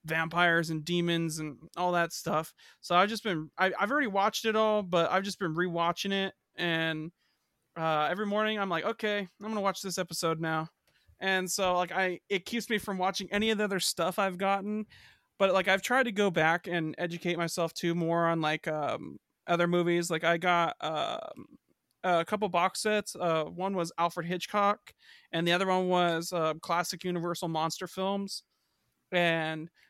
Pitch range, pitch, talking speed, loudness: 170-195 Hz, 175 Hz, 190 wpm, -30 LUFS